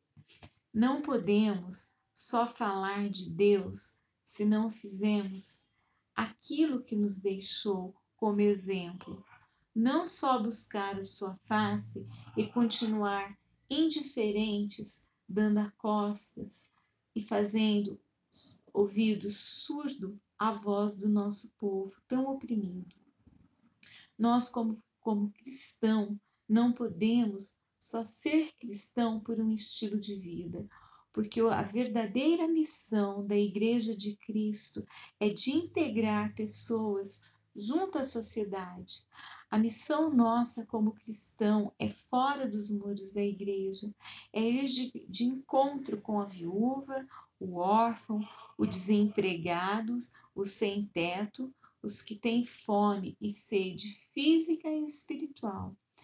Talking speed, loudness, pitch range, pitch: 110 wpm, -33 LUFS, 200-235 Hz, 215 Hz